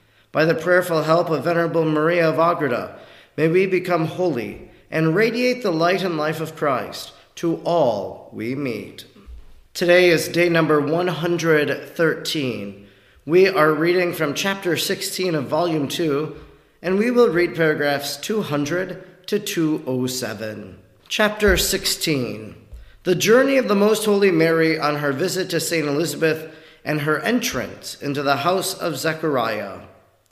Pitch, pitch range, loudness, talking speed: 160 Hz, 145-180 Hz, -20 LUFS, 140 wpm